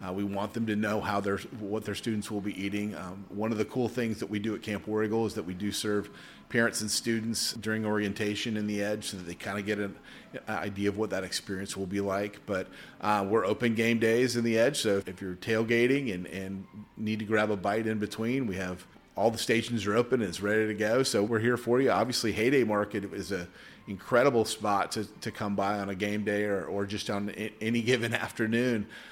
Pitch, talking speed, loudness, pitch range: 105 Hz, 240 wpm, -30 LUFS, 100-115 Hz